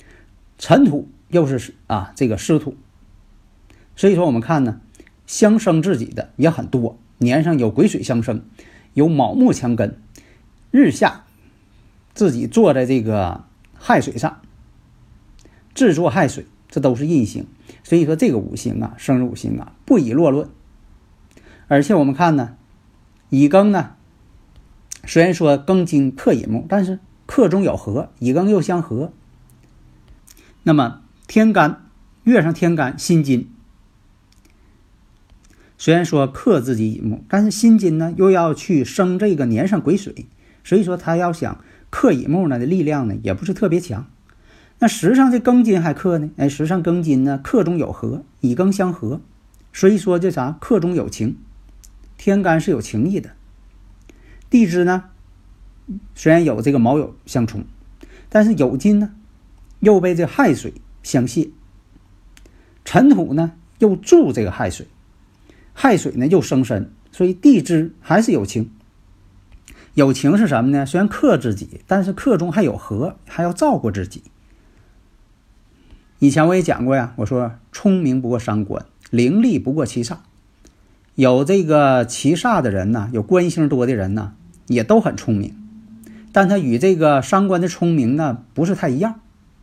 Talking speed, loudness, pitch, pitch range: 215 characters per minute, -17 LUFS, 140 Hz, 110-180 Hz